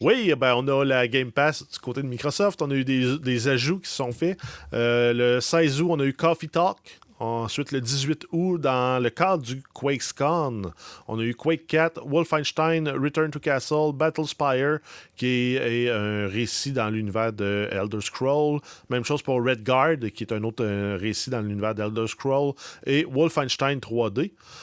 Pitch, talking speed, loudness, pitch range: 135 Hz, 190 wpm, -25 LUFS, 120-150 Hz